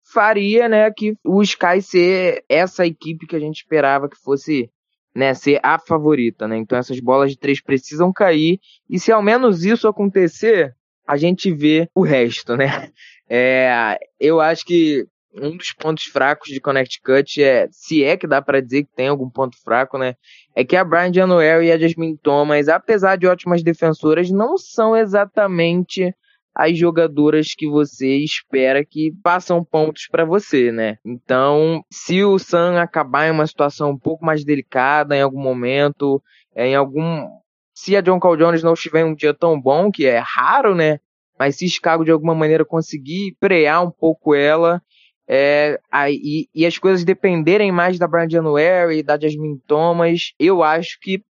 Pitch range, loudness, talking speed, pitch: 145-180 Hz, -16 LUFS, 175 wpm, 160 Hz